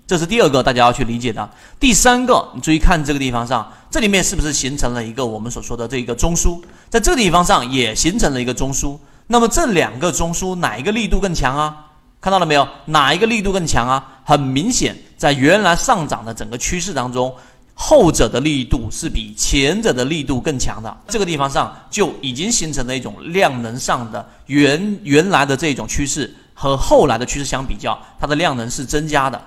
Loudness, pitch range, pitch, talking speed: -17 LUFS, 125-170 Hz, 140 Hz, 325 characters per minute